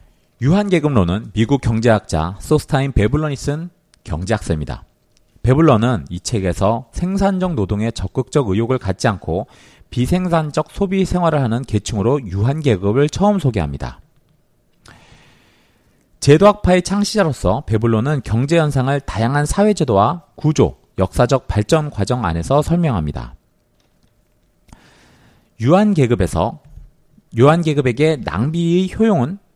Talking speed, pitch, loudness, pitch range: 285 characters per minute, 130 Hz, -17 LUFS, 105-160 Hz